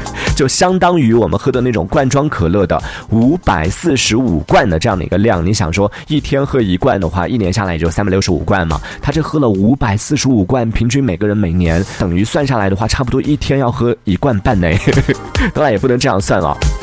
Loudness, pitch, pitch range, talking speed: -14 LUFS, 110 Hz, 95-135 Hz, 340 characters per minute